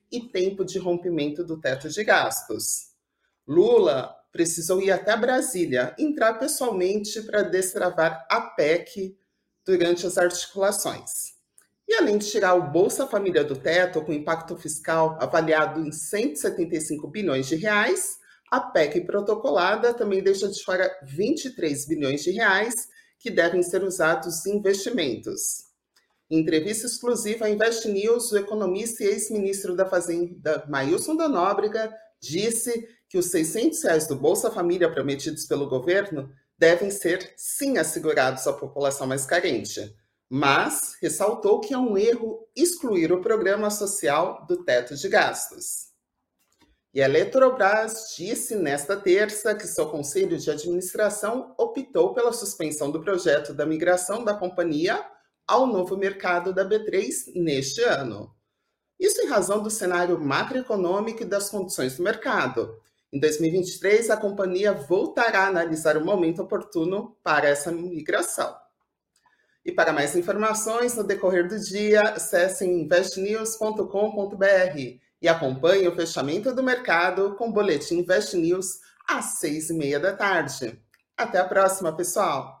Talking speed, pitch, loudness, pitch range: 135 wpm, 195 Hz, -24 LUFS, 170-225 Hz